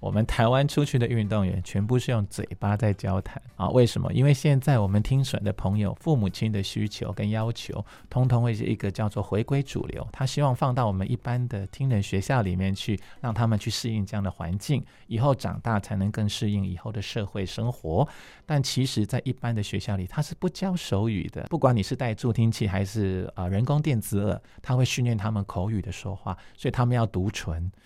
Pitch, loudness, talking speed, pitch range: 110 Hz, -27 LUFS, 325 characters per minute, 100-125 Hz